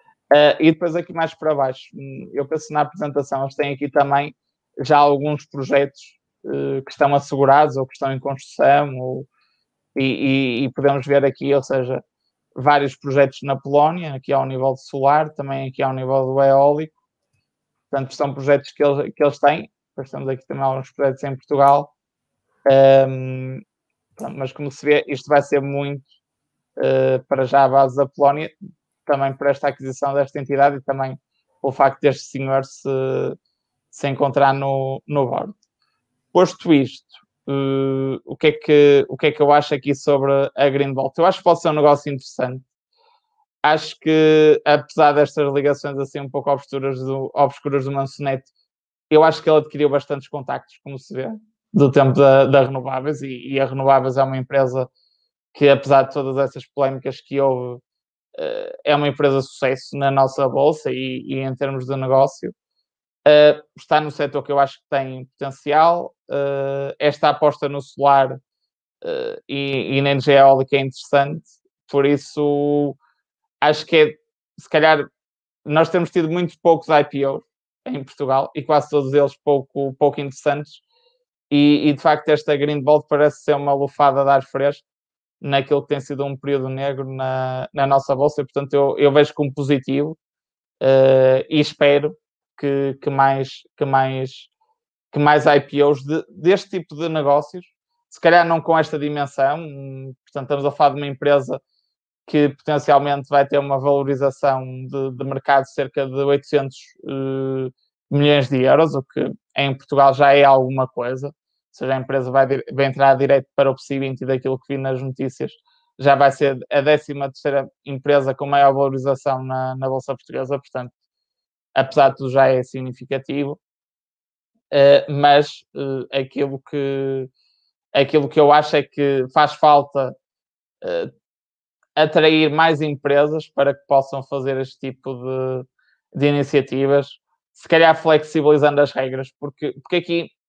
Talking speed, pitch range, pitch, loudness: 165 wpm, 135-150 Hz, 140 Hz, -18 LUFS